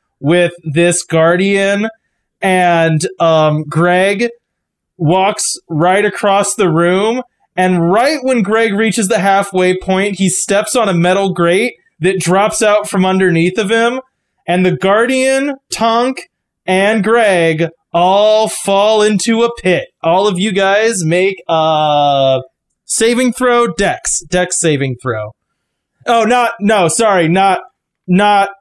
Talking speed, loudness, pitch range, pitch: 130 wpm, -12 LUFS, 175-220 Hz, 195 Hz